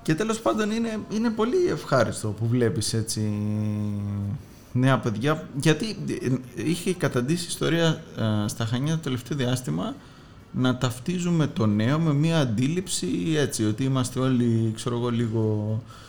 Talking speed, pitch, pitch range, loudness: 135 wpm, 125 Hz, 110-160 Hz, -25 LUFS